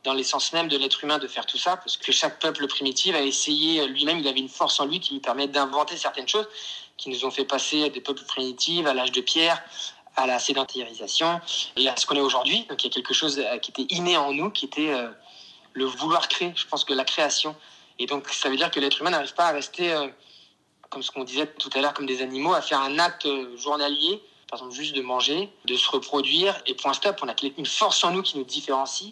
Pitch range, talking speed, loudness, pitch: 135-170 Hz, 245 wpm, -24 LUFS, 145 Hz